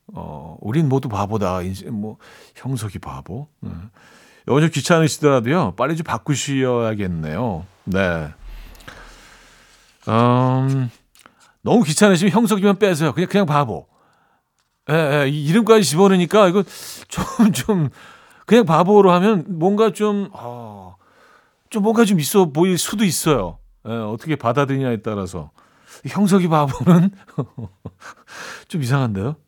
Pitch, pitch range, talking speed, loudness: 145 Hz, 115-185 Hz, 245 characters per minute, -18 LUFS